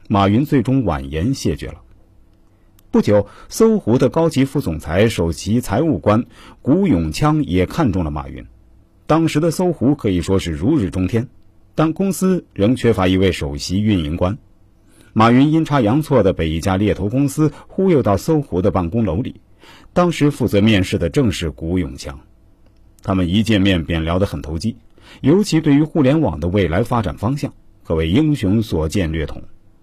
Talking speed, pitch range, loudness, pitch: 260 characters per minute, 90-135 Hz, -17 LUFS, 105 Hz